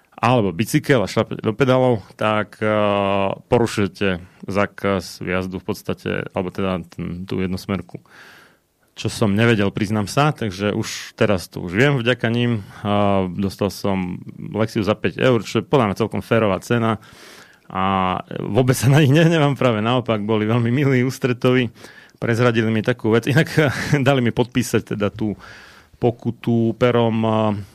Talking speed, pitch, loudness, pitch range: 150 wpm, 110 Hz, -20 LUFS, 100-125 Hz